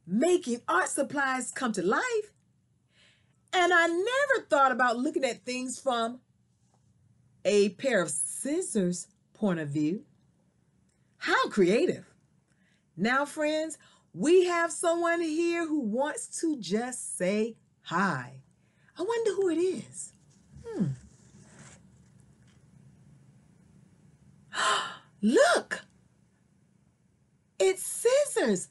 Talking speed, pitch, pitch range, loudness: 95 wpm, 265 Hz, 200-335 Hz, -28 LUFS